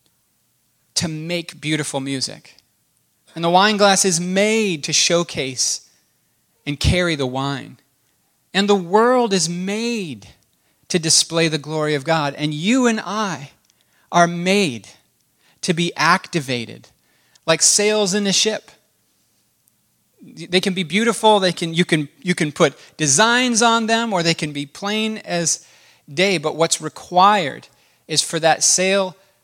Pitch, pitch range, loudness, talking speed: 175 Hz, 155-200 Hz, -18 LUFS, 140 wpm